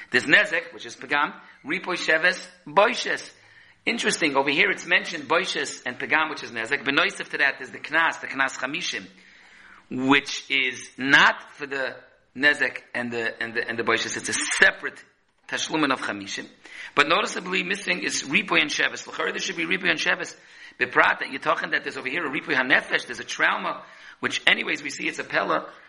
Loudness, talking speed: -23 LUFS, 190 wpm